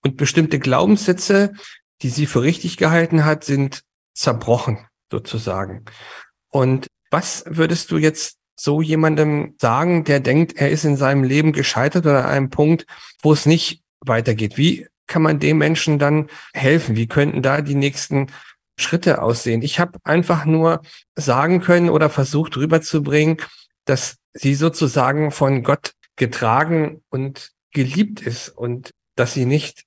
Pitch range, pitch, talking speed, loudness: 135-160 Hz, 150 Hz, 145 wpm, -18 LUFS